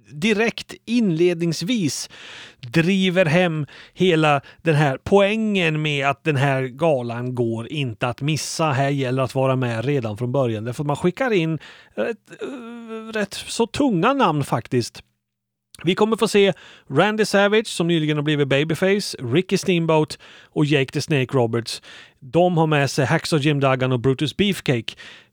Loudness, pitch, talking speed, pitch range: -20 LUFS, 155 Hz, 150 wpm, 135-185 Hz